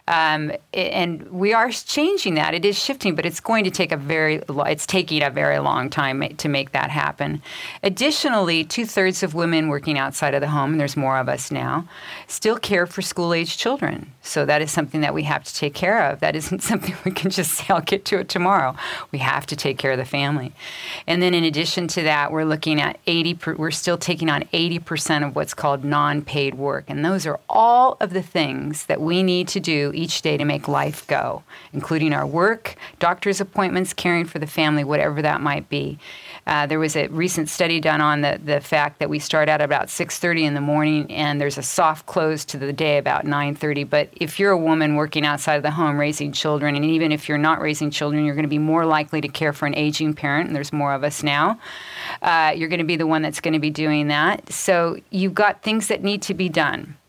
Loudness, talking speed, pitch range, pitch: -21 LUFS, 230 wpm, 150-175 Hz, 155 Hz